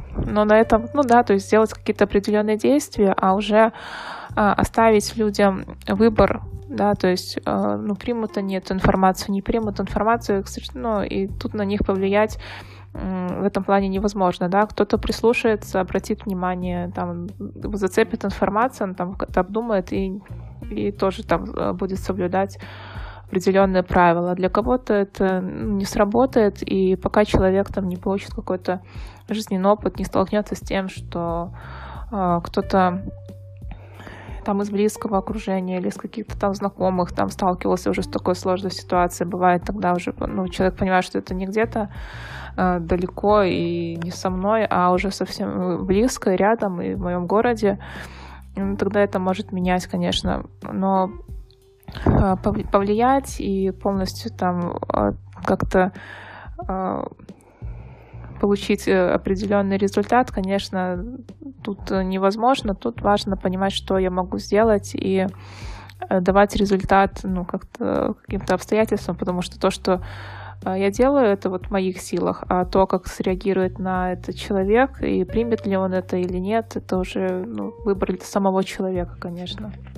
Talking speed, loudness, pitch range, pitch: 140 wpm, -21 LUFS, 180-205 Hz, 190 Hz